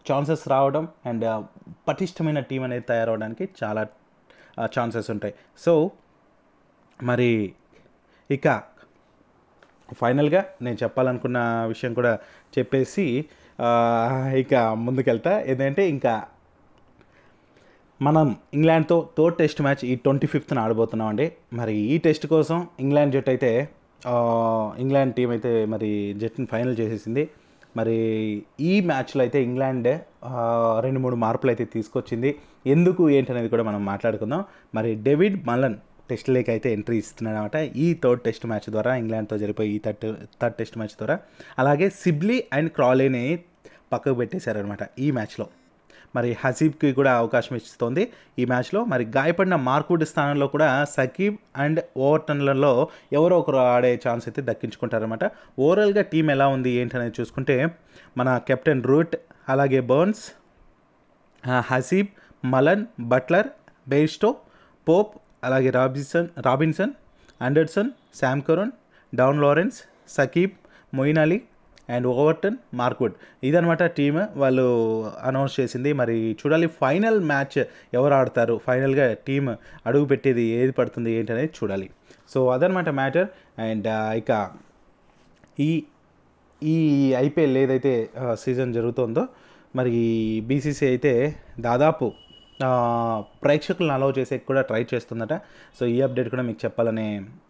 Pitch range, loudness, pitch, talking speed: 115-155 Hz, -23 LUFS, 130 Hz, 120 wpm